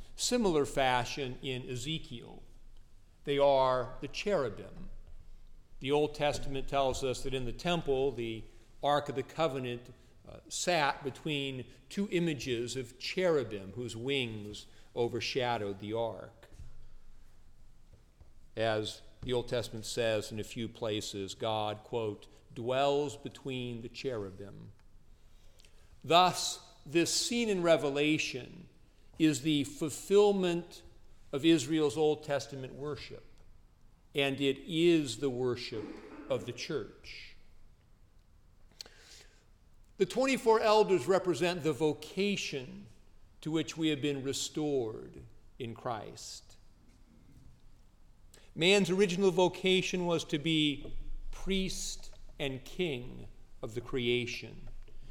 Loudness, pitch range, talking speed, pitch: -32 LUFS, 110-155 Hz, 105 wpm, 130 Hz